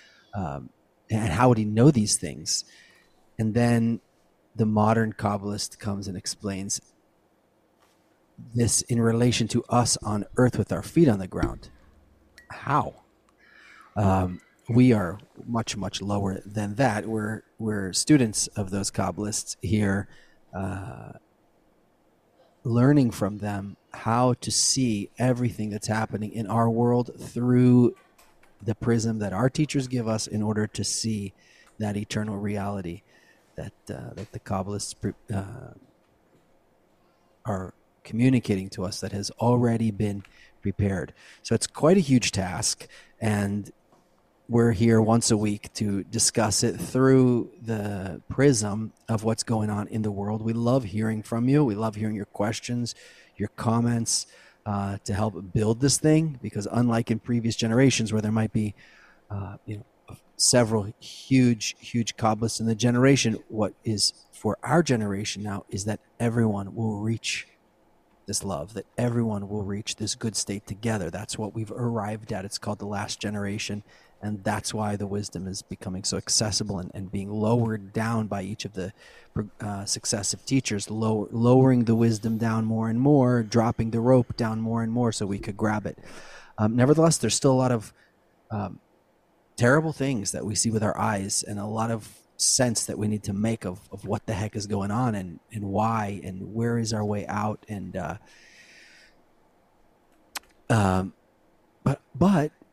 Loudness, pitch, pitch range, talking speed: -25 LUFS, 110 Hz, 100-120 Hz, 160 wpm